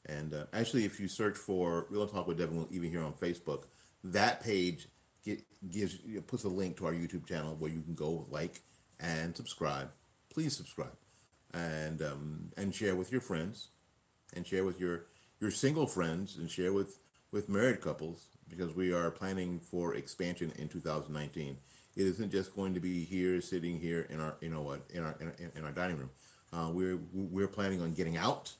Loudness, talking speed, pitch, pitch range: -37 LUFS, 195 wpm, 85 Hz, 80-95 Hz